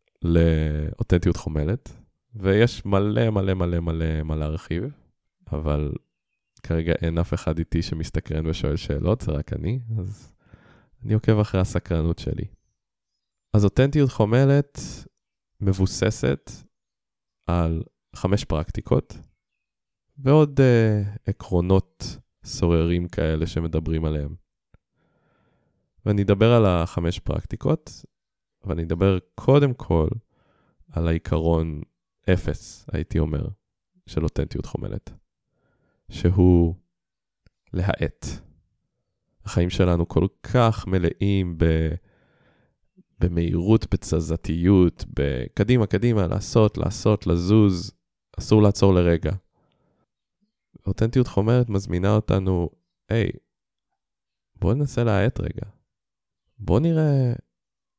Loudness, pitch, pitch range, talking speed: -23 LUFS, 95 Hz, 85-110 Hz, 90 wpm